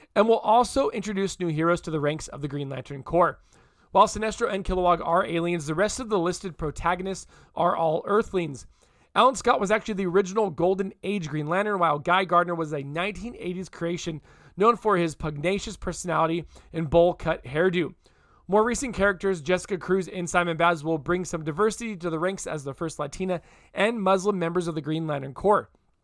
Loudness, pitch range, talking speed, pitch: -25 LUFS, 165-200 Hz, 185 wpm, 175 Hz